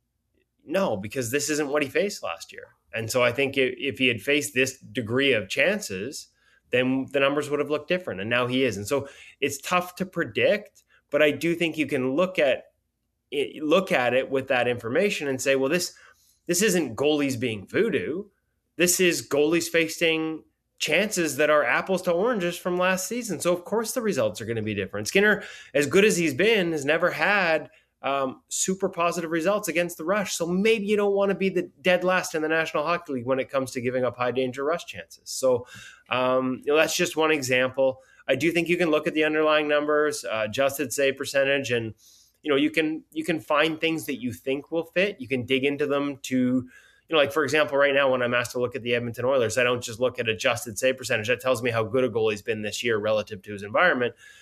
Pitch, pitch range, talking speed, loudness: 145 Hz, 130-170 Hz, 225 wpm, -24 LUFS